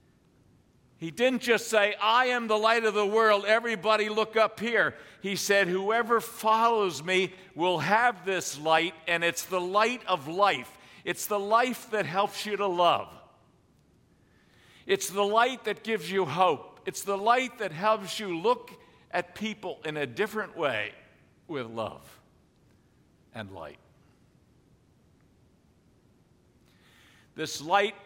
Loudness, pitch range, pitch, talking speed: -27 LUFS, 180-220 Hz, 205 Hz, 135 wpm